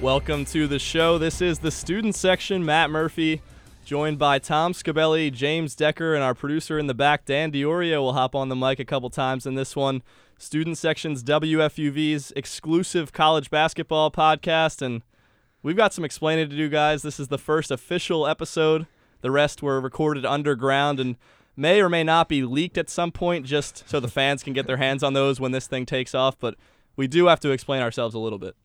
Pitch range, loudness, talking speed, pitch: 135-160 Hz, -23 LUFS, 205 wpm, 150 Hz